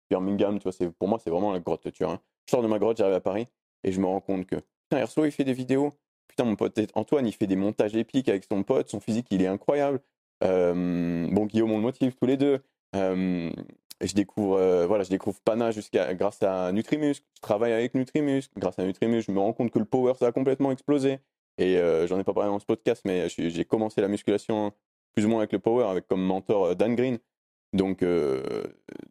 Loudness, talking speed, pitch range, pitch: -27 LUFS, 245 wpm, 95-125 Hz, 105 Hz